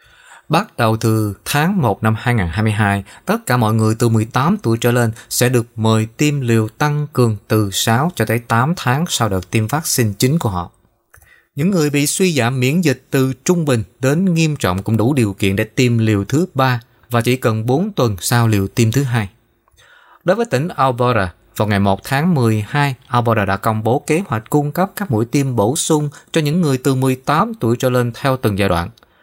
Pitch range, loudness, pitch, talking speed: 110-145 Hz, -16 LUFS, 125 Hz, 210 wpm